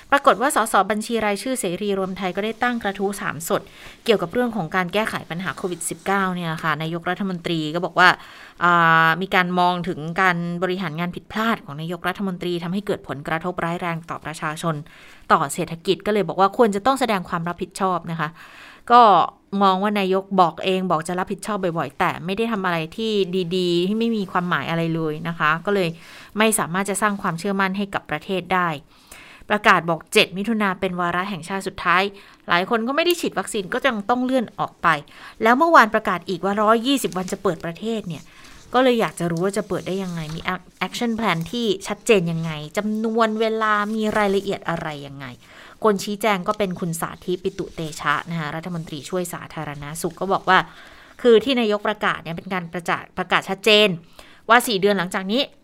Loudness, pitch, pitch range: -21 LUFS, 185 Hz, 170-210 Hz